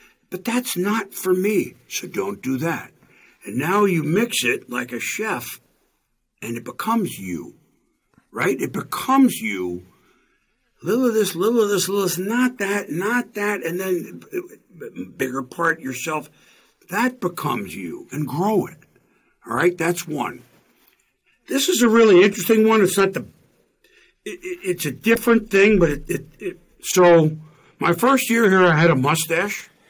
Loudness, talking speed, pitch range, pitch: -20 LUFS, 165 wpm, 155-220 Hz, 185 Hz